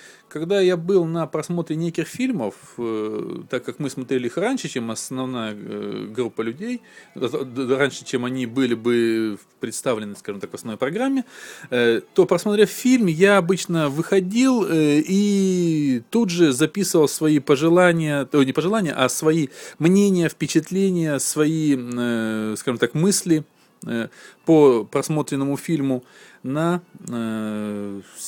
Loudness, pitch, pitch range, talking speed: -21 LUFS, 155 Hz, 125-180 Hz, 115 wpm